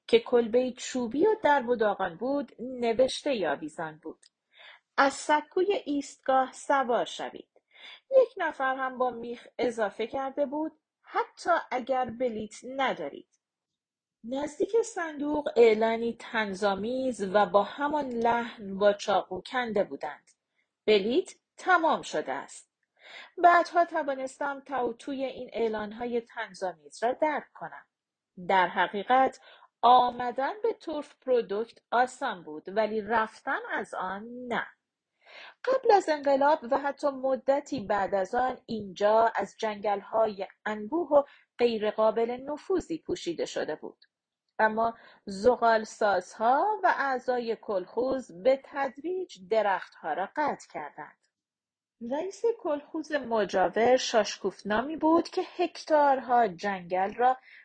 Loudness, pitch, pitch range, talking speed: -28 LUFS, 250 Hz, 220-290 Hz, 110 wpm